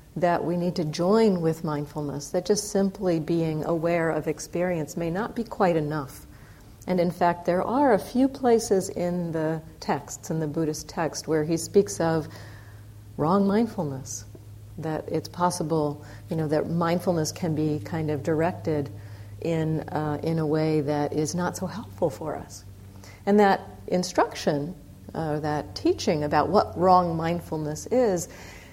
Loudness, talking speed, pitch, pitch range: -26 LUFS, 160 wpm, 160 Hz, 150-180 Hz